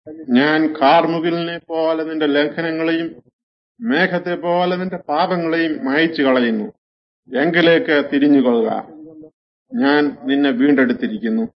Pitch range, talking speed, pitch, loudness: 145-175 Hz, 85 wpm, 160 Hz, -17 LUFS